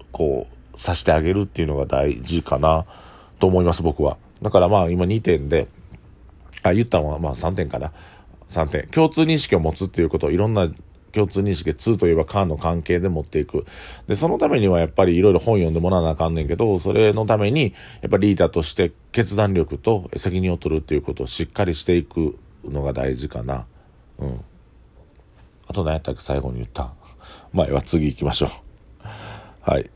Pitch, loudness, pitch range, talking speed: 85 Hz, -21 LUFS, 75-95 Hz, 375 characters per minute